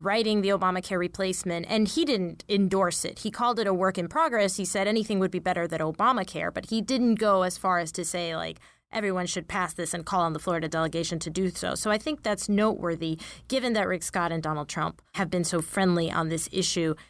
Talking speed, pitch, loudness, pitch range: 230 wpm, 185 Hz, -27 LUFS, 170-205 Hz